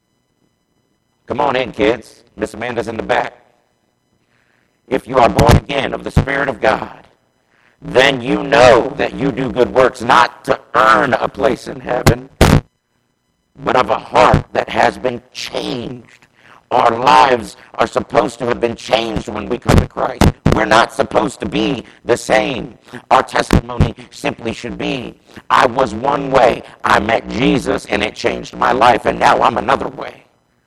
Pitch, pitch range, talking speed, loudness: 120 Hz, 110-125 Hz, 165 wpm, -15 LUFS